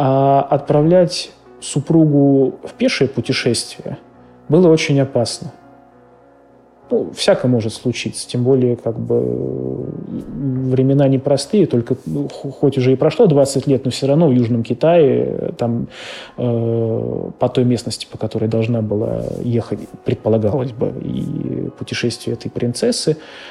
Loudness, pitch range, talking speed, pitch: -17 LUFS, 115-140 Hz, 125 wpm, 125 Hz